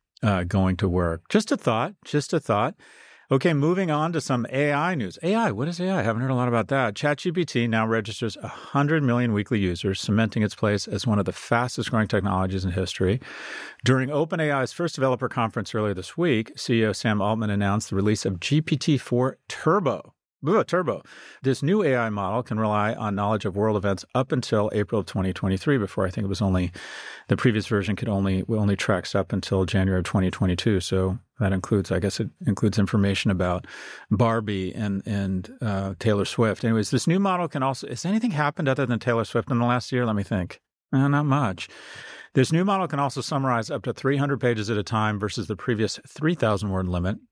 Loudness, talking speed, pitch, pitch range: -24 LUFS, 200 wpm, 115 Hz, 100-135 Hz